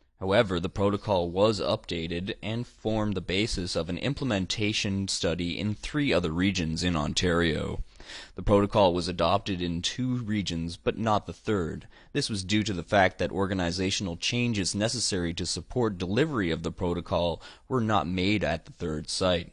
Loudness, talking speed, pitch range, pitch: -28 LUFS, 165 wpm, 85-105 Hz, 95 Hz